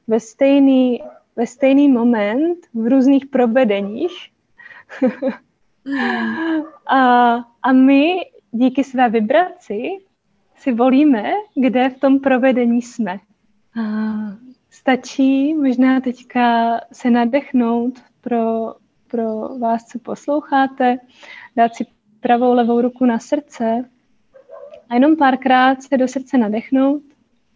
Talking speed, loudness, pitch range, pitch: 100 wpm, -17 LUFS, 235-275 Hz, 255 Hz